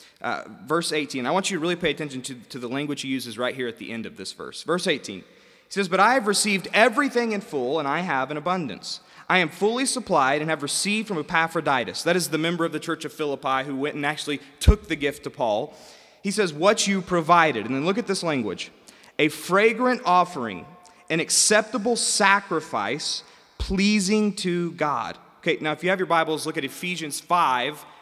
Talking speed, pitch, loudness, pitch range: 210 wpm, 170 Hz, -23 LUFS, 150-195 Hz